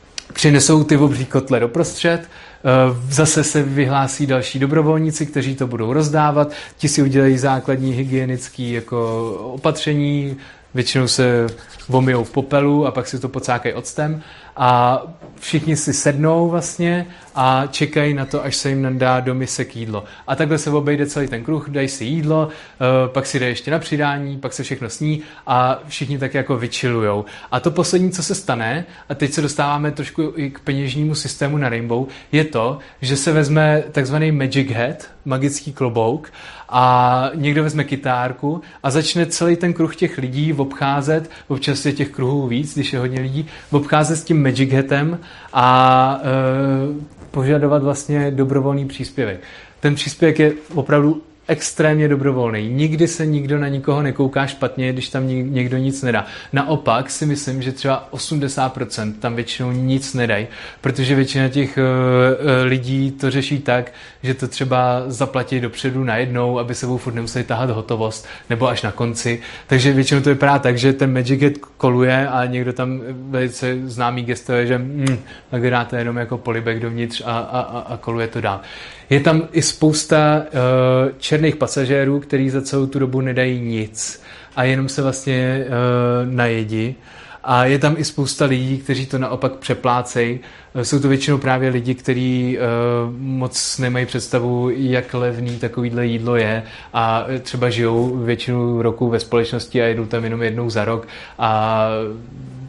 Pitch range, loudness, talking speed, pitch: 125-145 Hz, -18 LUFS, 160 wpm, 130 Hz